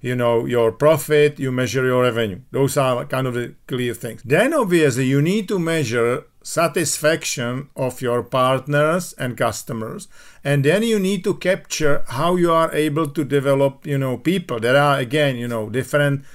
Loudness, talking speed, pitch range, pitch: -19 LUFS, 175 wpm, 125-155 Hz, 140 Hz